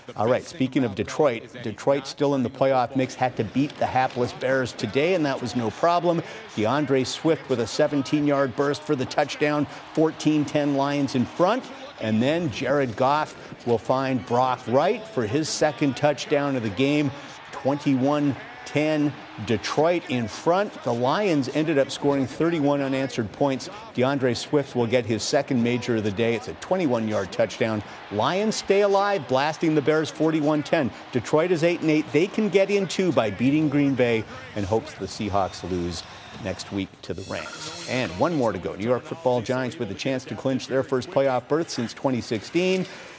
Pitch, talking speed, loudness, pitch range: 135 Hz, 180 wpm, -24 LUFS, 120-150 Hz